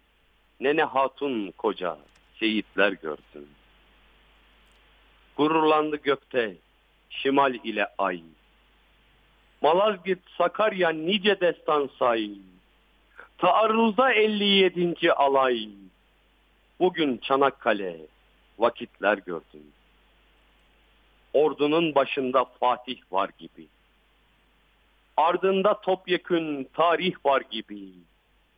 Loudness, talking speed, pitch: -24 LUFS, 65 wpm, 140 Hz